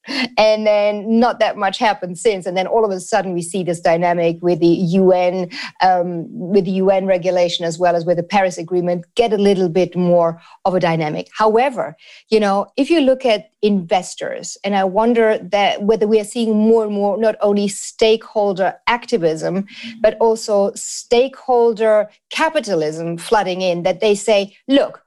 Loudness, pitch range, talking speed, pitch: -17 LUFS, 180-225 Hz, 175 wpm, 205 Hz